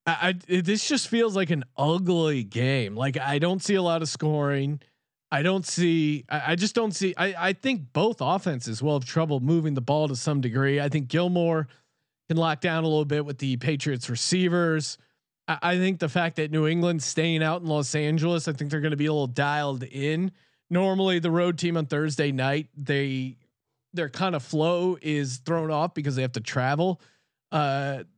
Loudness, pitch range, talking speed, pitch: -26 LUFS, 140-175 Hz, 205 wpm, 155 Hz